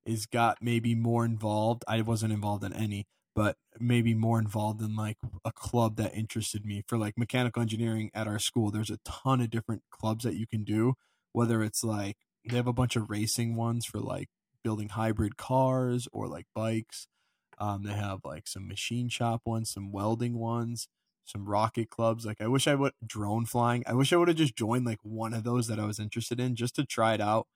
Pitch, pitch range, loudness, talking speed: 115 Hz, 110-120 Hz, -31 LUFS, 215 wpm